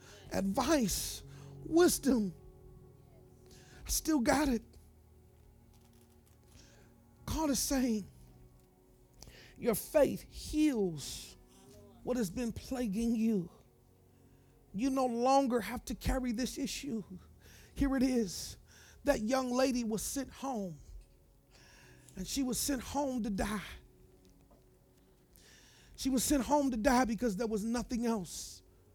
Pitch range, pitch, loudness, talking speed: 160-265 Hz, 235 Hz, -34 LUFS, 110 wpm